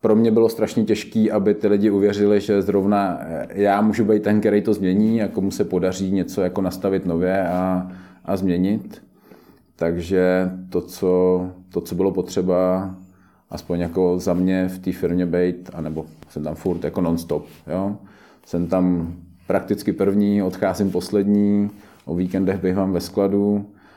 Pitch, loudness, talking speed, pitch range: 95 Hz, -21 LUFS, 160 wpm, 90-100 Hz